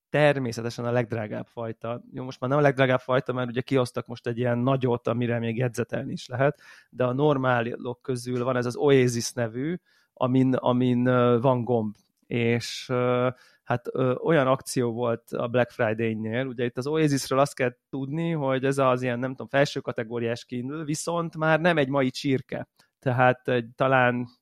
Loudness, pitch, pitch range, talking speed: -26 LUFS, 125 Hz, 120-135 Hz, 165 wpm